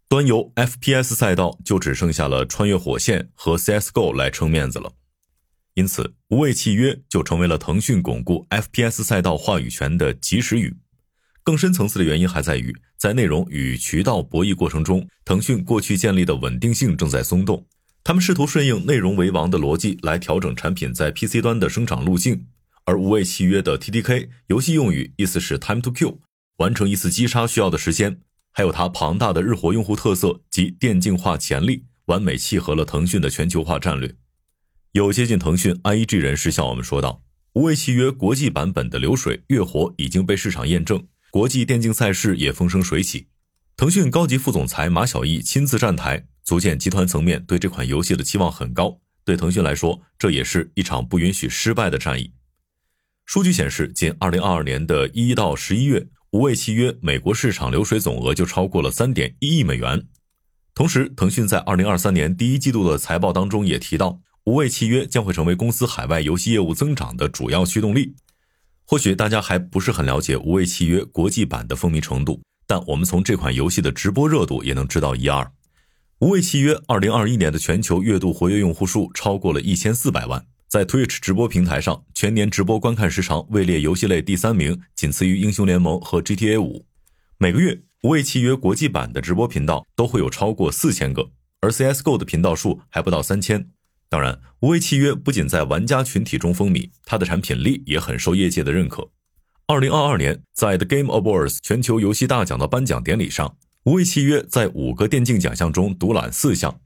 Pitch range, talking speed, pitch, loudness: 80-120 Hz, 325 characters per minute, 95 Hz, -20 LUFS